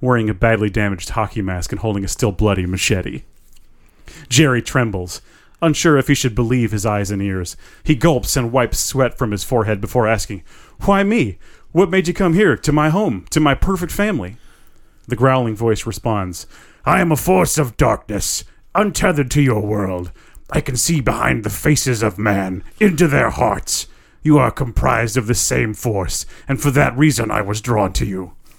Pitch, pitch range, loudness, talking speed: 115 Hz, 100-150 Hz, -17 LUFS, 185 wpm